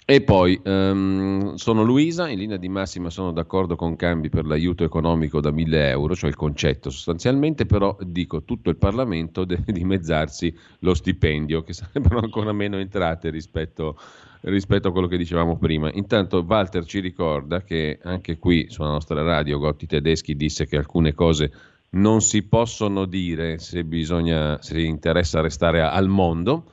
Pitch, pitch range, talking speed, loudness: 85 Hz, 80-95 Hz, 160 wpm, -22 LUFS